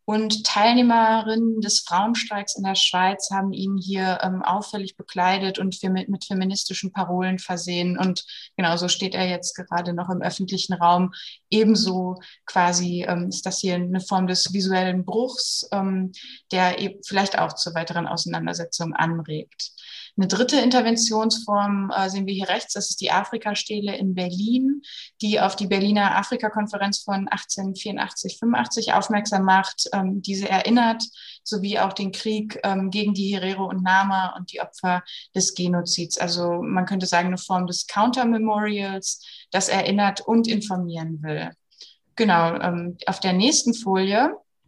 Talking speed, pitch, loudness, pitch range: 140 wpm, 195 Hz, -22 LUFS, 185-210 Hz